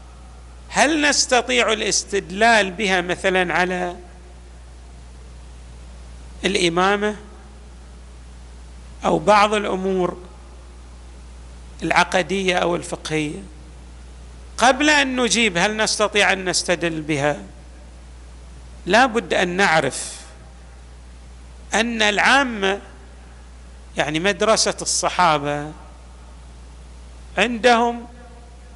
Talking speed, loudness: 65 wpm, -18 LUFS